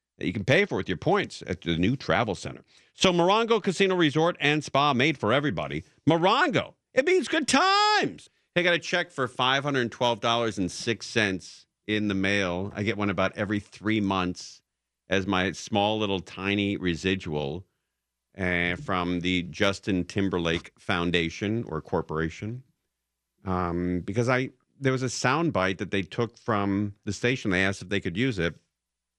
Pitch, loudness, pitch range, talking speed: 100 Hz, -26 LUFS, 90-130 Hz, 160 wpm